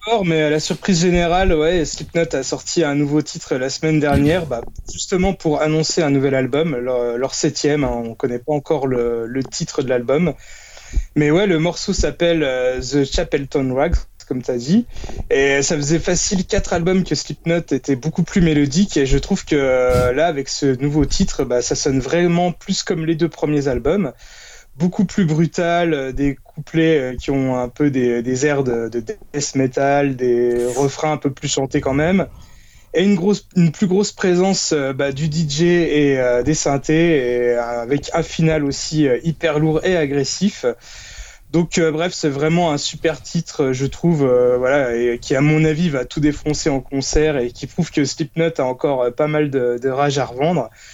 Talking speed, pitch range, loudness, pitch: 195 wpm, 135-170 Hz, -18 LUFS, 150 Hz